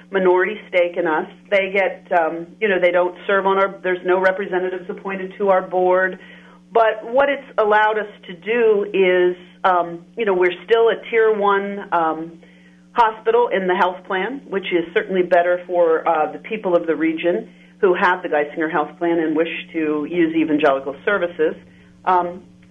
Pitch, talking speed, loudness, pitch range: 180 Hz, 175 wpm, -19 LUFS, 165-195 Hz